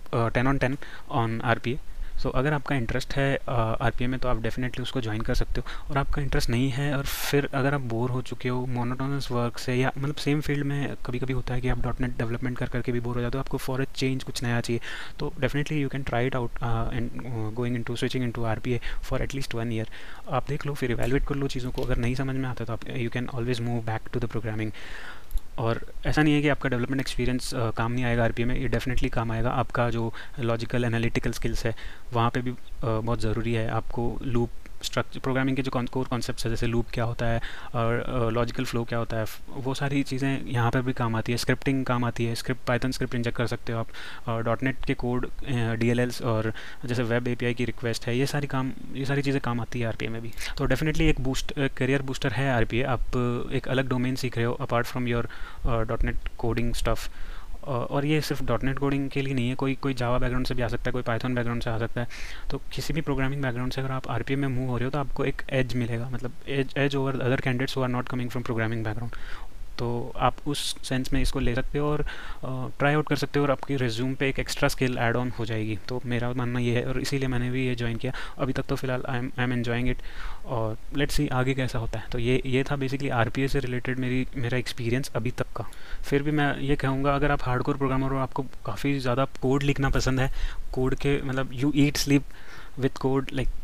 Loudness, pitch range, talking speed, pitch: -28 LUFS, 120-135 Hz, 250 wpm, 125 Hz